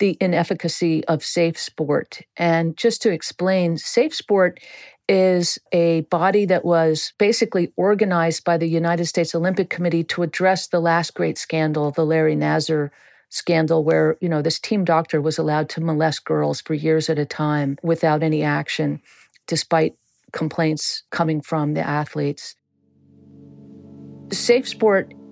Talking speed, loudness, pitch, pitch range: 145 wpm, -20 LUFS, 165 Hz, 155-180 Hz